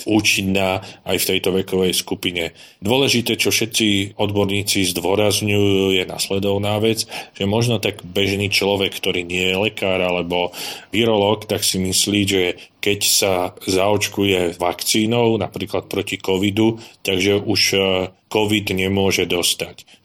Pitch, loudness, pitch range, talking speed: 100 Hz, -18 LUFS, 95-105 Hz, 125 wpm